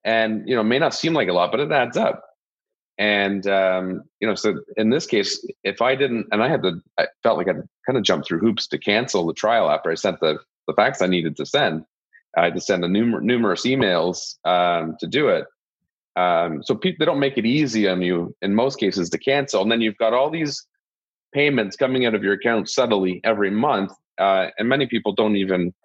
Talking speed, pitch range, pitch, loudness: 230 wpm, 95-140 Hz, 110 Hz, -21 LUFS